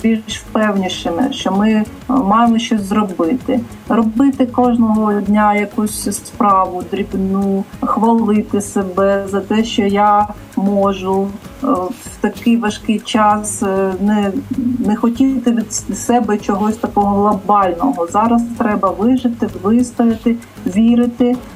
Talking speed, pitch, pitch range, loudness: 105 wpm, 215 Hz, 205-240 Hz, -15 LUFS